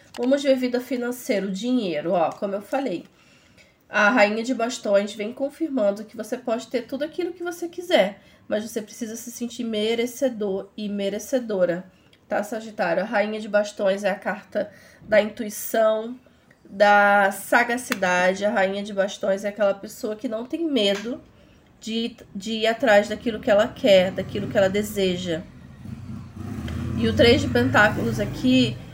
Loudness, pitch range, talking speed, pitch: -23 LUFS, 195-245 Hz, 155 wpm, 215 Hz